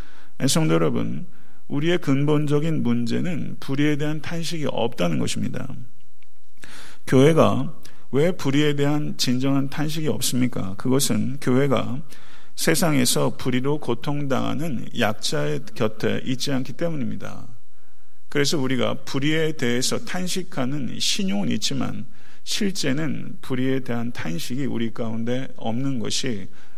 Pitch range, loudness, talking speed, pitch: 125-150 Hz, -24 LUFS, 275 characters per minute, 135 Hz